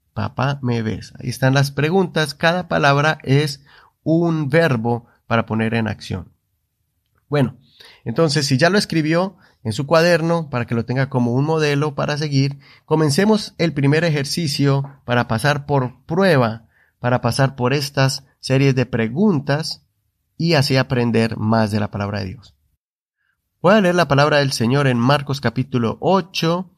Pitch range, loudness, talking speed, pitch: 115-155 Hz, -18 LUFS, 155 wpm, 135 Hz